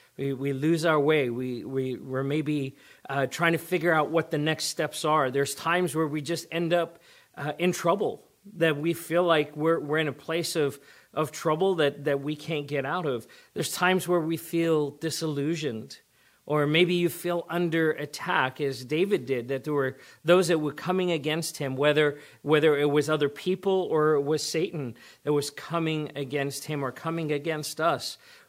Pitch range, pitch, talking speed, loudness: 145-165 Hz, 155 Hz, 190 wpm, -27 LUFS